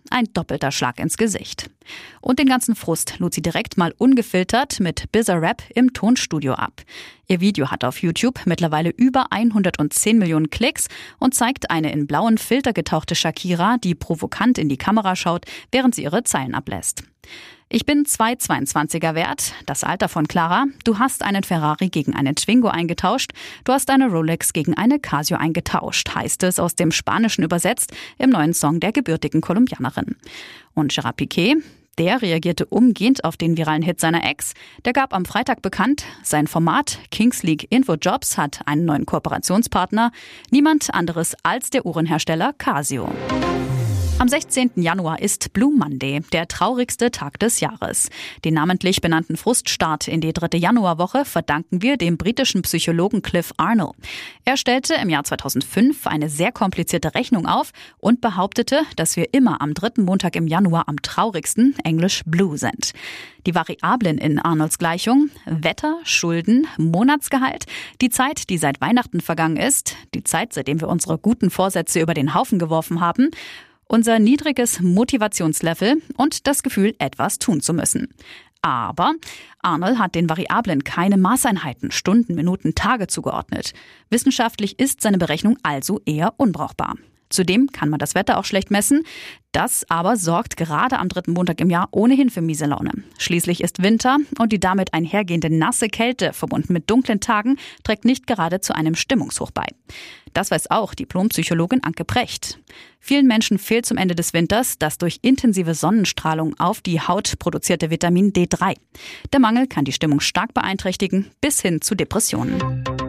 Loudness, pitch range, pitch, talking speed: -19 LUFS, 165-240 Hz, 185 Hz, 160 wpm